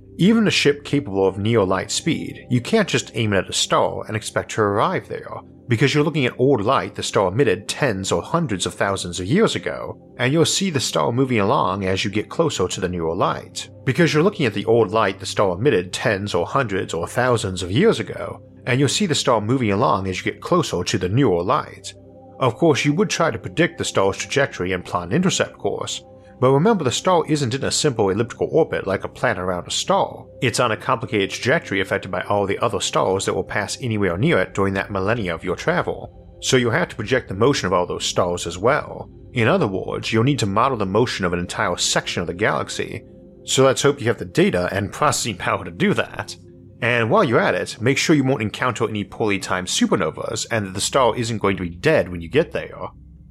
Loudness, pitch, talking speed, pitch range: -20 LUFS, 110 Hz, 235 wpm, 95-135 Hz